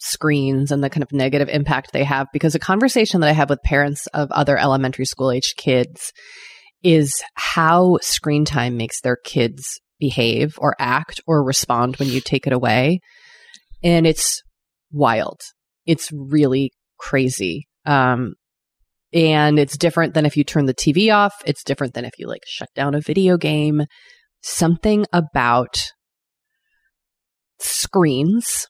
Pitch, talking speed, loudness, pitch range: 145 Hz, 150 wpm, -18 LUFS, 135-165 Hz